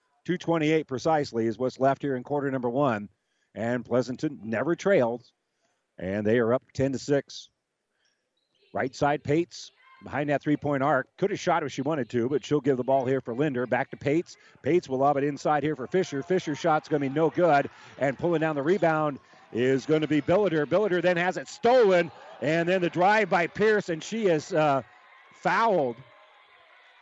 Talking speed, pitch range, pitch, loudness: 195 wpm, 130-165 Hz, 145 Hz, -26 LUFS